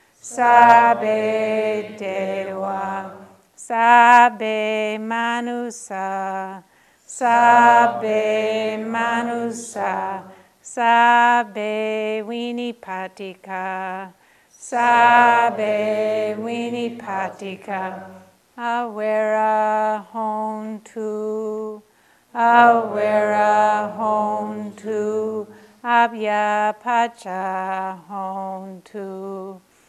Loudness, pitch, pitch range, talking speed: -19 LUFS, 215 Hz, 195-235 Hz, 40 wpm